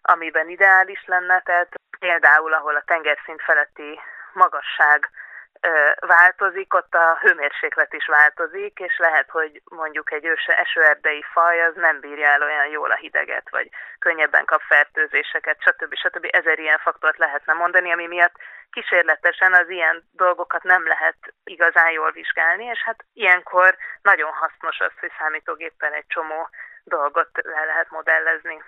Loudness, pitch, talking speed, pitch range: -18 LUFS, 170 Hz, 145 wpm, 160-185 Hz